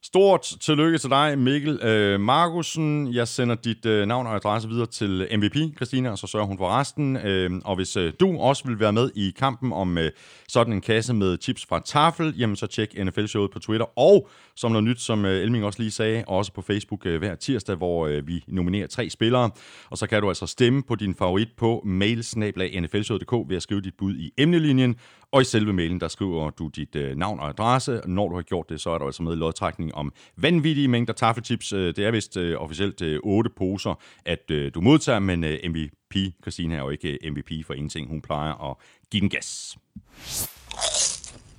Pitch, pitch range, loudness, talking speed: 105 Hz, 90-120 Hz, -24 LUFS, 200 wpm